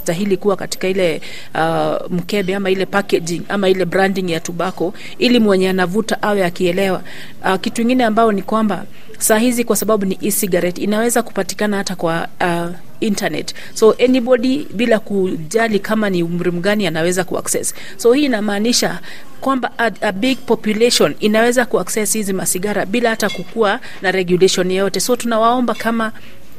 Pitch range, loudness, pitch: 185-225 Hz, -16 LUFS, 200 Hz